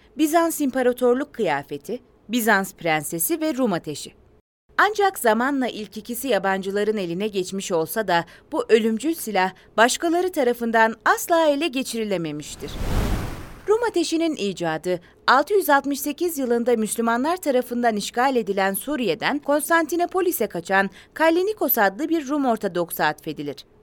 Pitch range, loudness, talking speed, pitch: 195-305 Hz, -22 LUFS, 110 wpm, 235 Hz